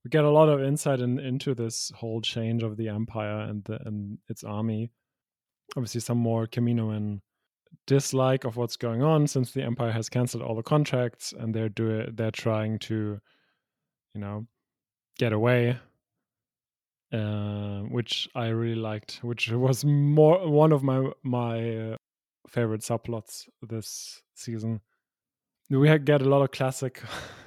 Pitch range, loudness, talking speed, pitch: 110-130 Hz, -27 LUFS, 155 wpm, 115 Hz